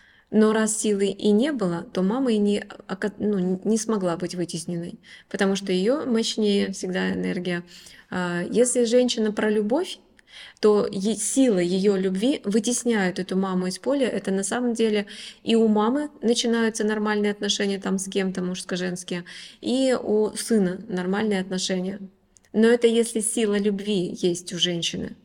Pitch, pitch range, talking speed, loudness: 205 Hz, 185-225 Hz, 145 wpm, -23 LUFS